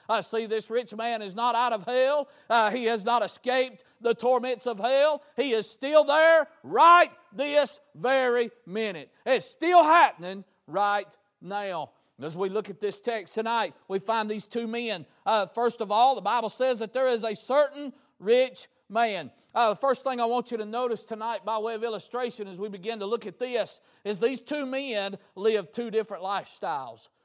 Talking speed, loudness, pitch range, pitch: 195 wpm, -26 LUFS, 215-255 Hz, 230 Hz